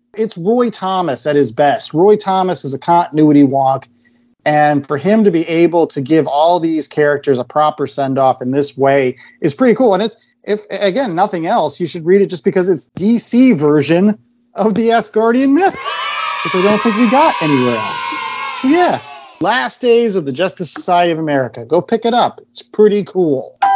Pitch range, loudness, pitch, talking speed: 145-225 Hz, -13 LUFS, 180 Hz, 190 wpm